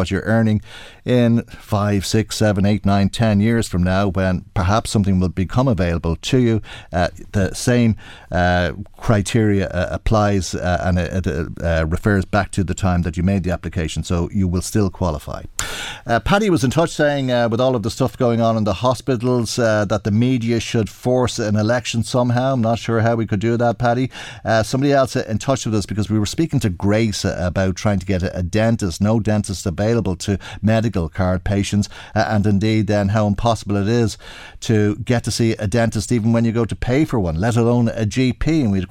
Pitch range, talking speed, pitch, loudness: 95-115 Hz, 210 wpm, 105 Hz, -19 LUFS